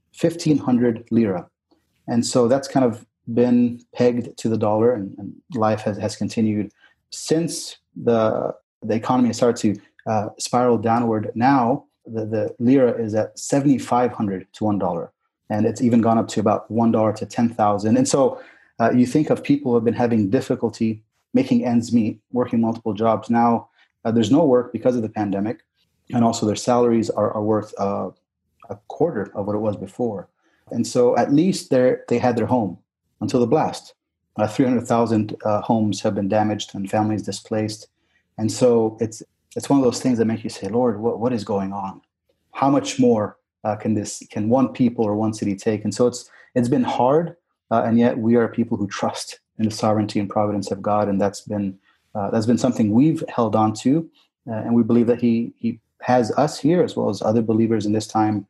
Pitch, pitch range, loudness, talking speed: 115 Hz, 105-120 Hz, -21 LUFS, 200 wpm